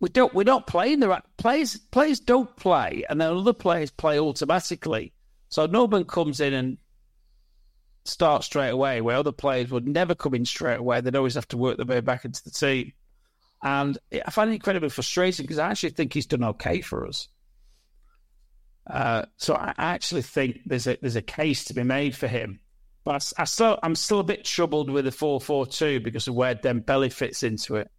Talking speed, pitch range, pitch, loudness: 205 wpm, 125-175 Hz, 145 Hz, -25 LUFS